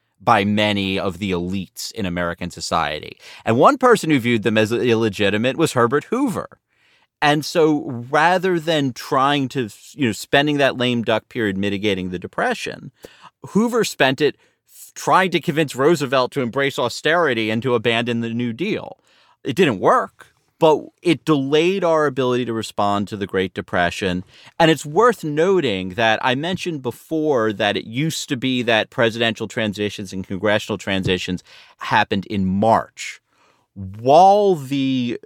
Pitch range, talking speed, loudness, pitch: 105-145 Hz, 150 wpm, -19 LUFS, 120 Hz